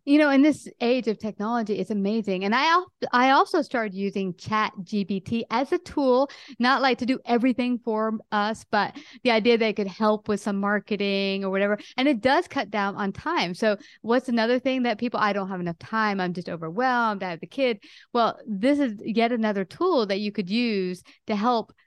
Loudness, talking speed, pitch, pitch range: -24 LUFS, 210 wpm, 220 Hz, 205-250 Hz